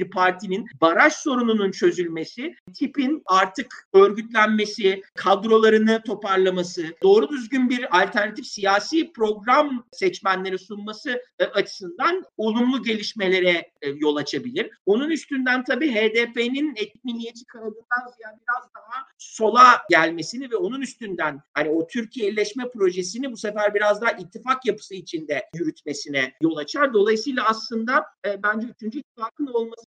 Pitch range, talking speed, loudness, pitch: 190-250 Hz, 120 wpm, -22 LUFS, 220 Hz